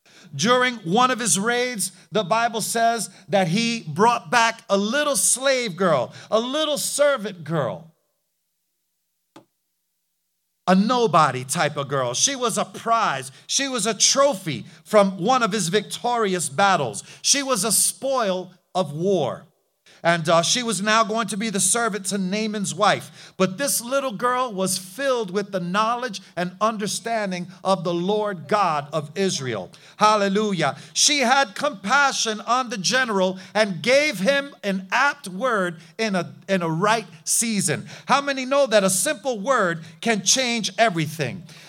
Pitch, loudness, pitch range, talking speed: 210 Hz, -21 LUFS, 180-240 Hz, 150 wpm